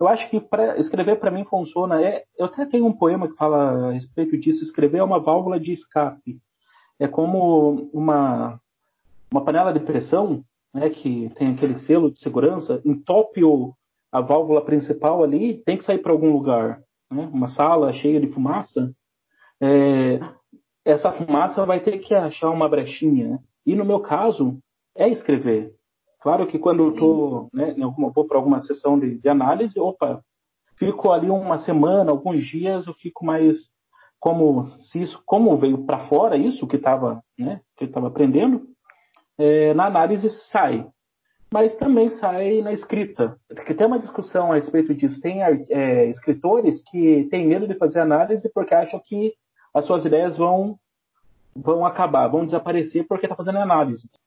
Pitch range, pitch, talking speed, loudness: 140-190 Hz, 155 Hz, 160 wpm, -20 LUFS